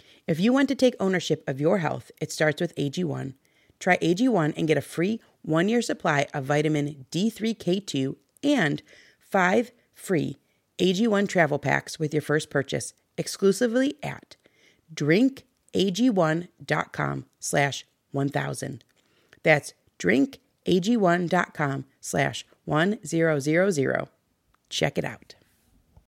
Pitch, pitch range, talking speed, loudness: 165 Hz, 150-200 Hz, 95 wpm, -25 LUFS